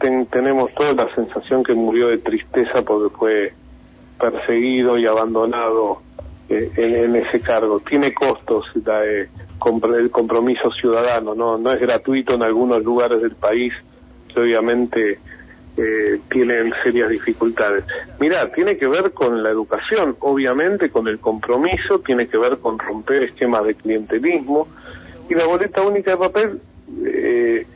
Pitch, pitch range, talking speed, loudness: 120 Hz, 110-145 Hz, 145 wpm, -18 LUFS